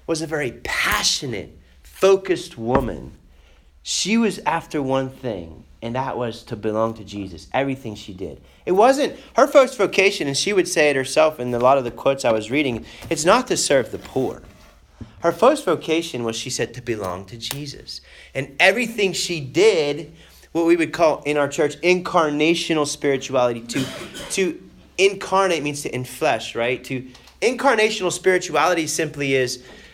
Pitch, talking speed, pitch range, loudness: 140 Hz, 165 wpm, 120-175 Hz, -20 LUFS